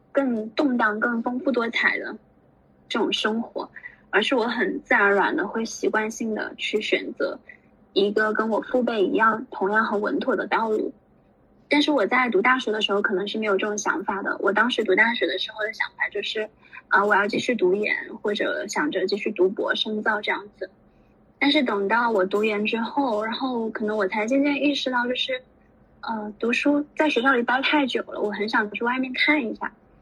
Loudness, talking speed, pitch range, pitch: -23 LUFS, 285 characters per minute, 210-260 Hz, 225 Hz